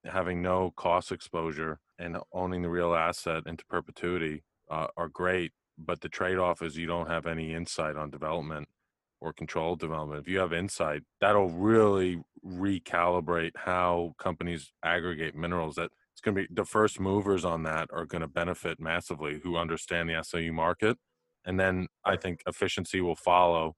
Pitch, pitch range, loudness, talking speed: 85 Hz, 80-90 Hz, -31 LUFS, 165 wpm